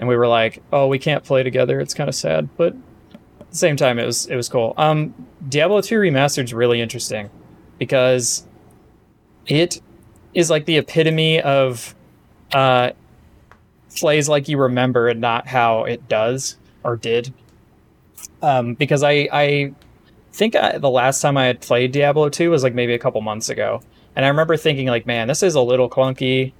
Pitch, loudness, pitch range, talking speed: 130 Hz, -18 LUFS, 120-150 Hz, 185 wpm